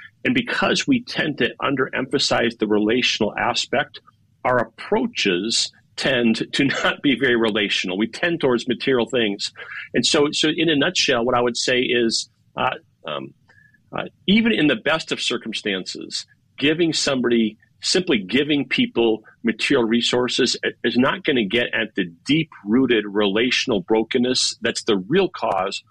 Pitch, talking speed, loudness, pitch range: 120 Hz, 145 wpm, -20 LUFS, 110-150 Hz